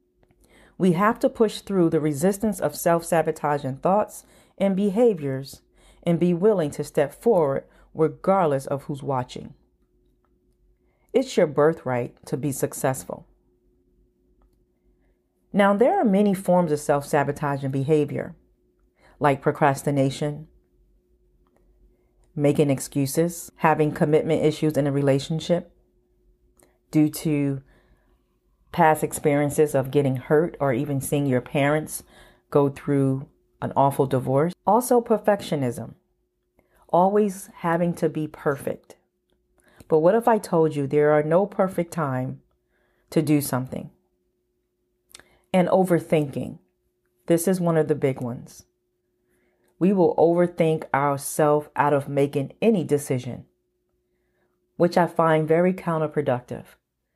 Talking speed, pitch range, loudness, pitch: 115 wpm, 130-170 Hz, -23 LUFS, 150 Hz